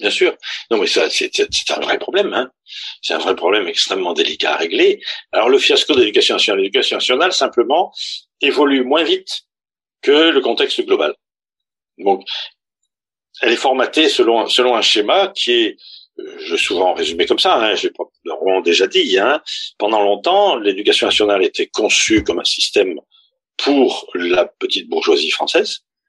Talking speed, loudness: 165 wpm, -15 LUFS